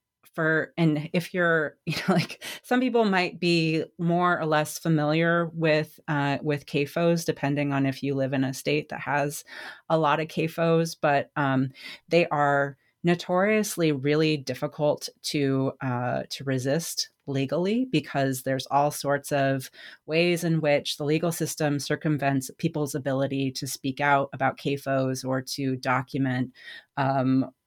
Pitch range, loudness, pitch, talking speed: 135-165 Hz, -26 LUFS, 150 Hz, 150 wpm